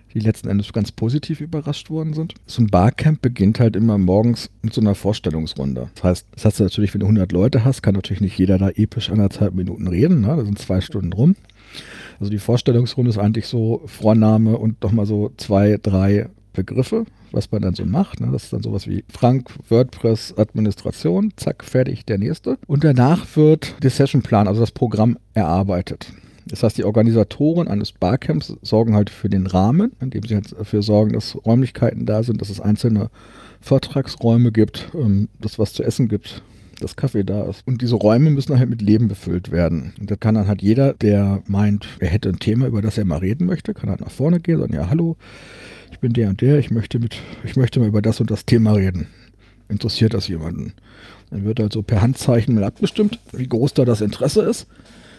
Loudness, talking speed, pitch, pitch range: -19 LUFS, 205 wpm, 110 Hz, 100-125 Hz